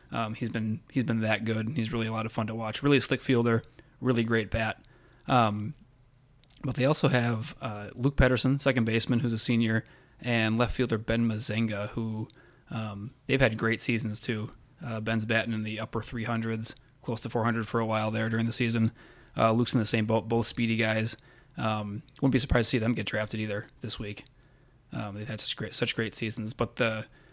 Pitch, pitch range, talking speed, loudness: 115 Hz, 110-125 Hz, 210 wpm, -29 LUFS